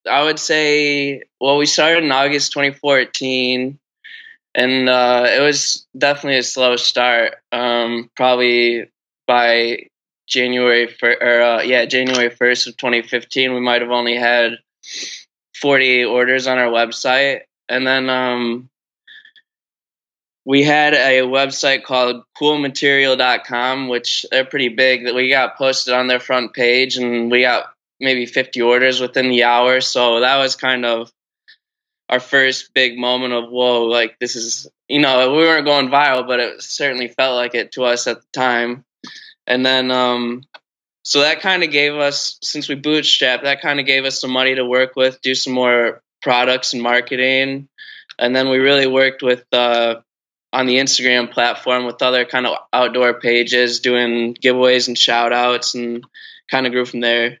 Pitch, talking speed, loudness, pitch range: 125 Hz, 160 wpm, -15 LUFS, 120-135 Hz